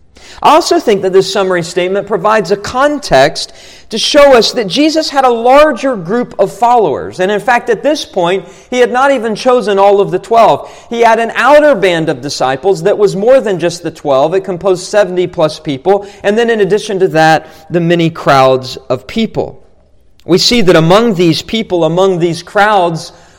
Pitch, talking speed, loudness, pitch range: 200 Hz, 190 wpm, -10 LUFS, 175-240 Hz